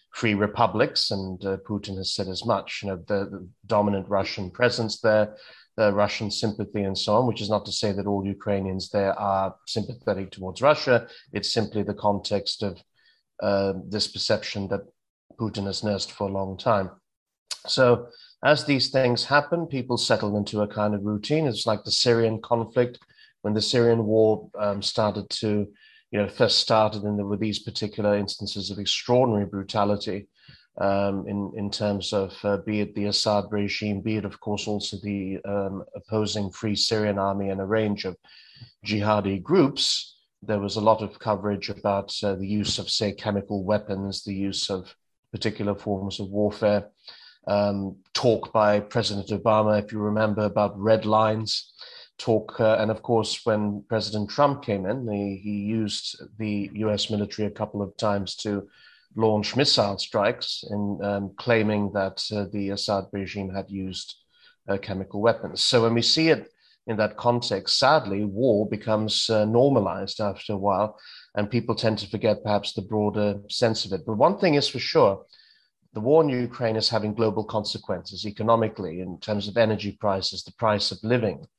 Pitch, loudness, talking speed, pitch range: 105 Hz, -25 LUFS, 175 wpm, 100-110 Hz